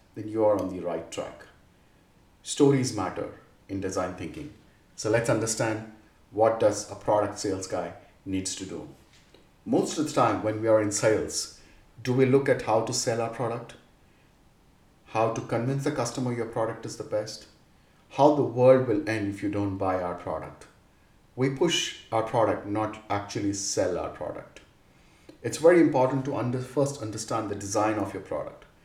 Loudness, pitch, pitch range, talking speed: -27 LUFS, 110 Hz, 105-130 Hz, 175 wpm